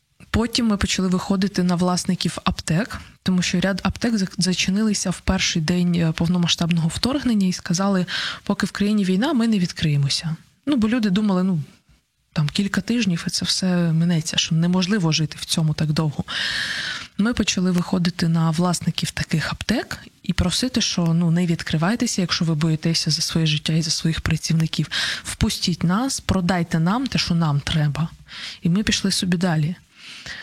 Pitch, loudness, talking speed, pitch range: 180 Hz, -21 LUFS, 160 wpm, 165-195 Hz